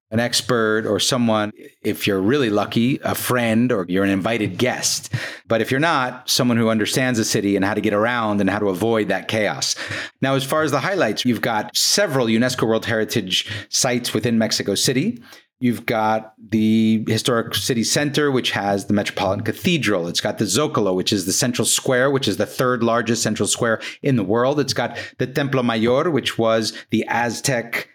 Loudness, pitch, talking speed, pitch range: -19 LUFS, 115 Hz, 195 wpm, 105-125 Hz